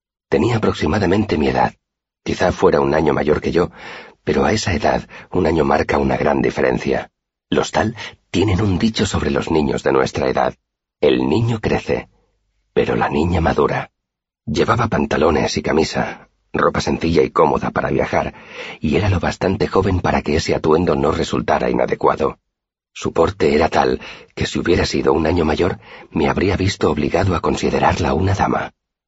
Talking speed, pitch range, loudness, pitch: 165 wpm, 90-110 Hz, -18 LUFS, 95 Hz